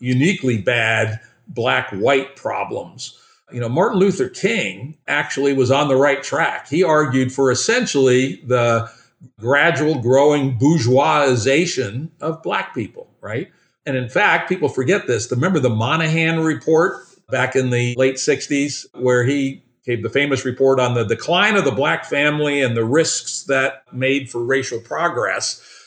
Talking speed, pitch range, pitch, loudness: 150 wpm, 125-155 Hz, 135 Hz, -18 LUFS